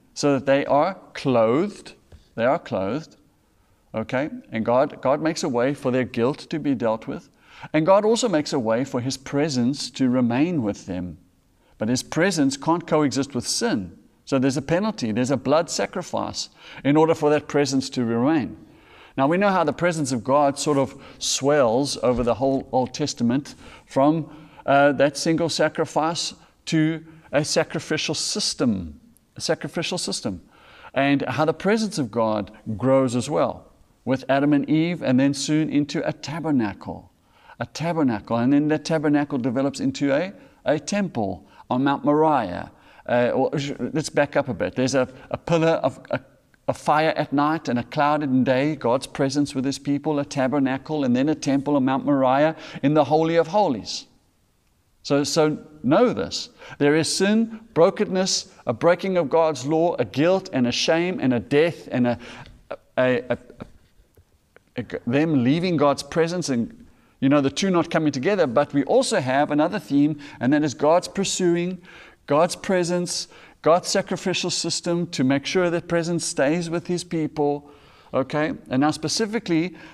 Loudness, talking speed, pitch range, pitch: -22 LUFS, 170 wpm, 135-165 Hz, 150 Hz